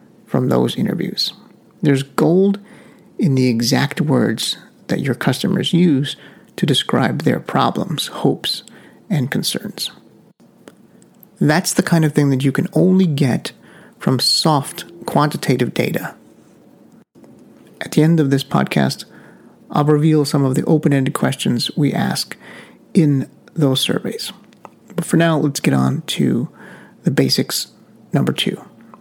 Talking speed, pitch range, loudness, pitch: 130 wpm, 135-170 Hz, -17 LUFS, 150 Hz